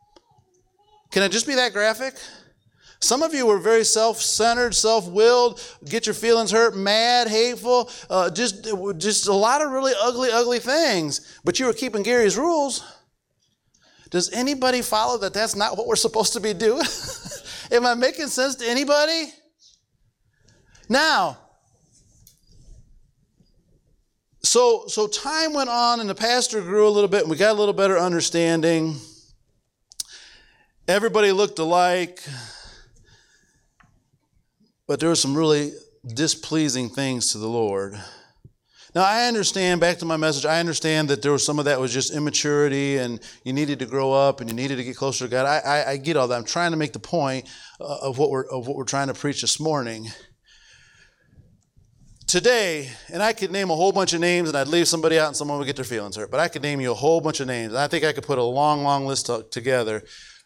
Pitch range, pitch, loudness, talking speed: 140-225 Hz, 175 Hz, -21 LUFS, 180 wpm